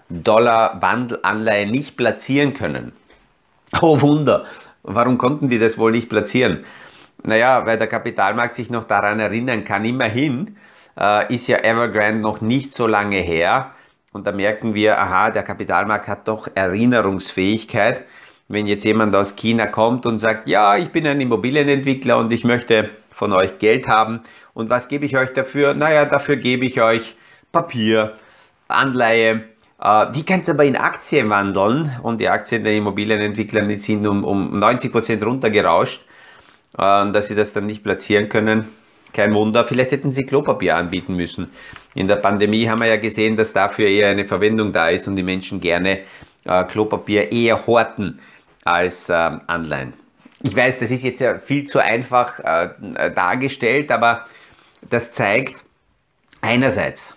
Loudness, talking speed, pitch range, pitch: -18 LUFS, 155 wpm, 105-125 Hz, 110 Hz